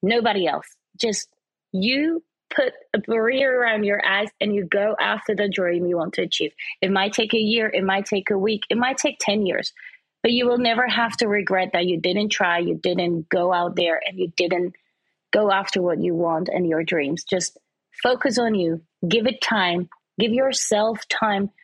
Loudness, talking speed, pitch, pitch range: -22 LUFS, 200 wpm, 205 Hz, 180-230 Hz